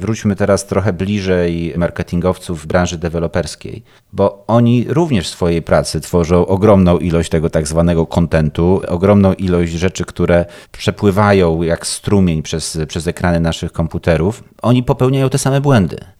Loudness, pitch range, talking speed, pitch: -15 LUFS, 85-100 Hz, 140 wpm, 90 Hz